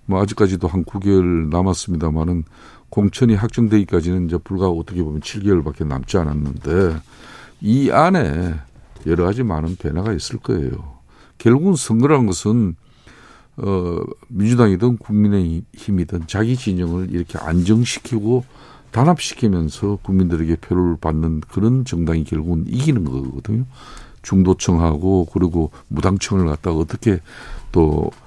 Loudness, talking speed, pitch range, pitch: -18 LUFS, 310 characters per minute, 85-110 Hz, 95 Hz